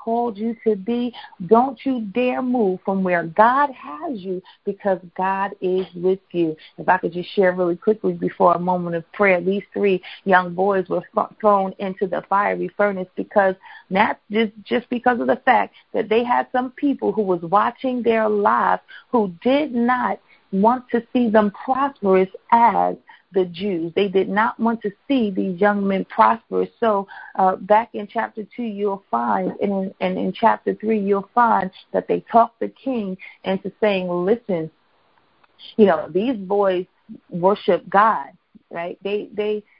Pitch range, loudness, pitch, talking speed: 185-230 Hz, -20 LUFS, 205 Hz, 170 wpm